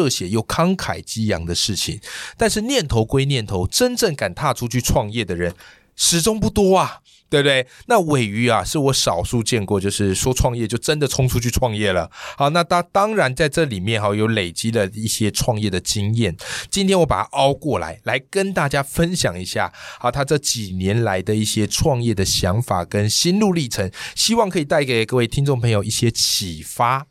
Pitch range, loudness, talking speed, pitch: 105-150 Hz, -19 LUFS, 290 characters per minute, 120 Hz